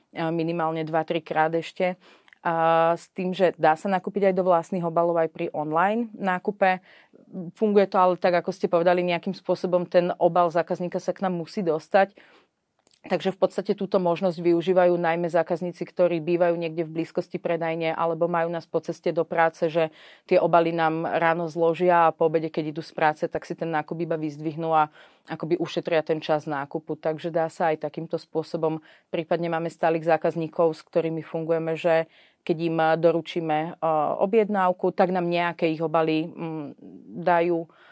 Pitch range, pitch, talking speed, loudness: 165-180 Hz, 170 Hz, 170 wpm, -24 LUFS